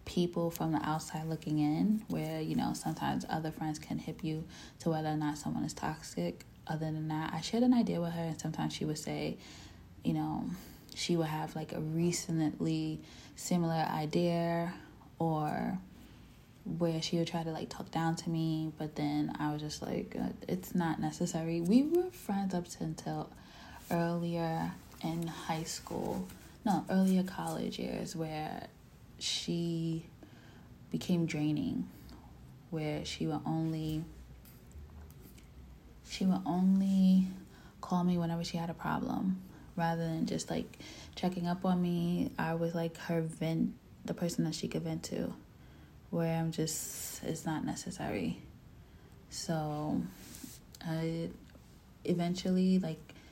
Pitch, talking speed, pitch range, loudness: 165 Hz, 145 wpm, 150-175 Hz, -35 LUFS